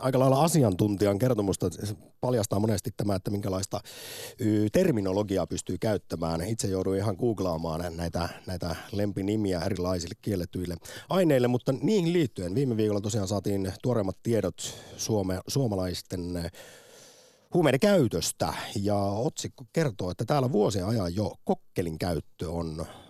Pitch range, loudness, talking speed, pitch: 95-120 Hz, -28 LUFS, 120 wpm, 105 Hz